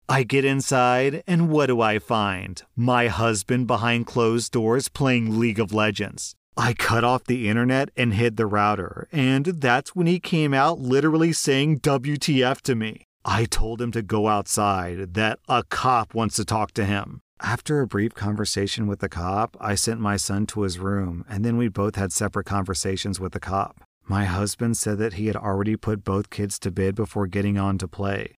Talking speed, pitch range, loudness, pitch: 195 wpm, 100-125 Hz, -23 LUFS, 110 Hz